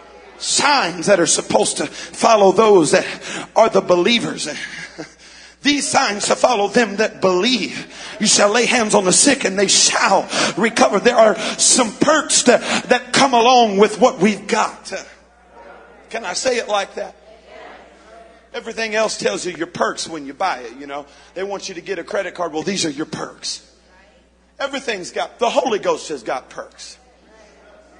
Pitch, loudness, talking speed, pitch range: 215 Hz, -16 LUFS, 170 wpm, 190-245 Hz